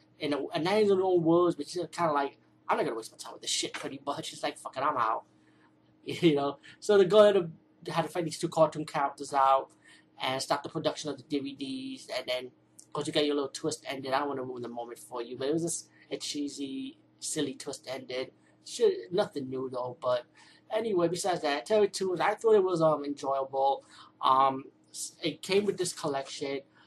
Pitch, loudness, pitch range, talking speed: 150 Hz, -30 LUFS, 135-175 Hz, 225 wpm